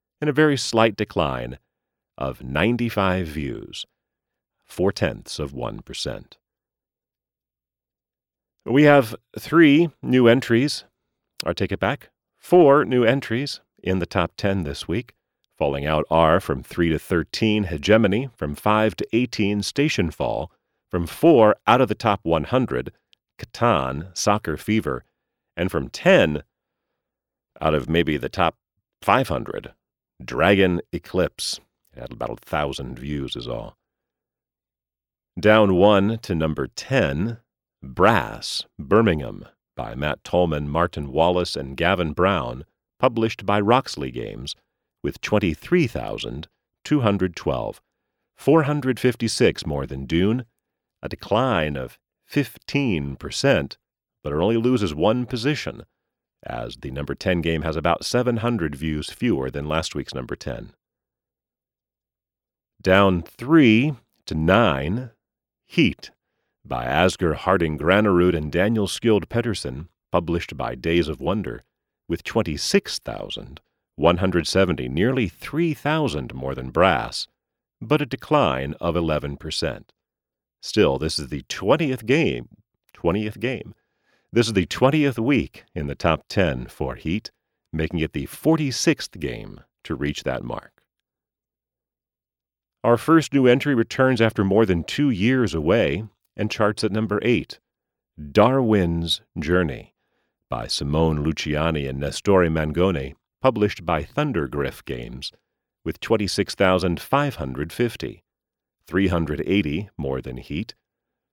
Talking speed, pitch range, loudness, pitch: 125 wpm, 75-115 Hz, -22 LUFS, 95 Hz